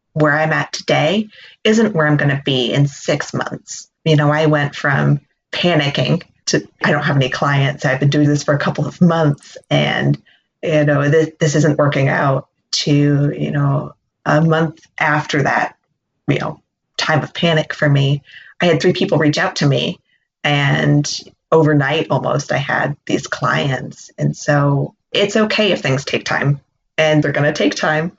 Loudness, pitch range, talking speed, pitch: -16 LUFS, 140-160 Hz, 180 wpm, 150 Hz